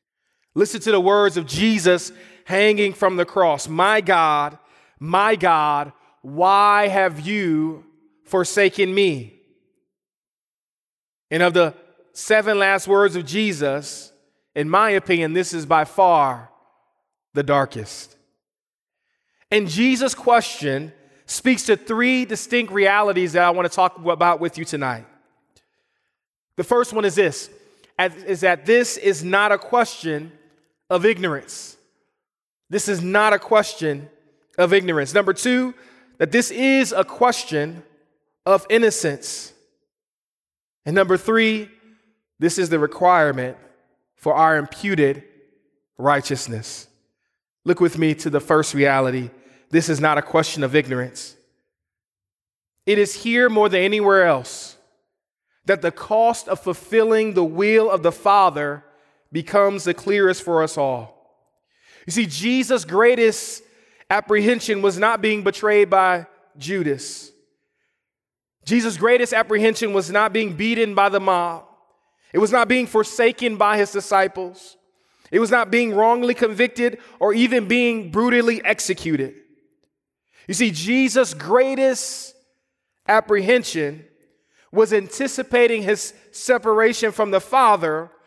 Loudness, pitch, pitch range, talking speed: -19 LUFS, 195 Hz, 160-225 Hz, 125 wpm